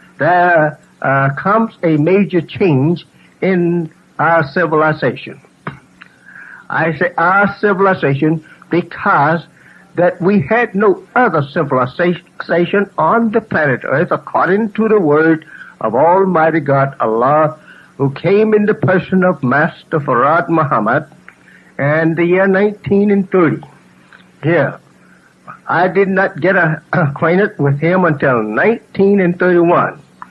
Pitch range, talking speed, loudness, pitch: 155-195 Hz, 110 wpm, -13 LUFS, 175 Hz